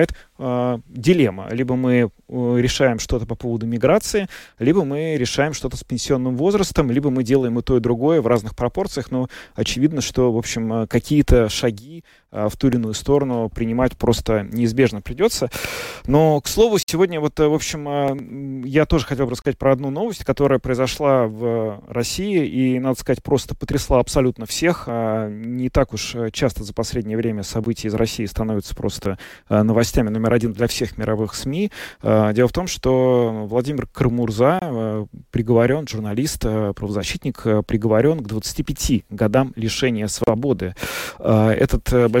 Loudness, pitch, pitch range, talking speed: -20 LUFS, 125 Hz, 115-140 Hz, 145 wpm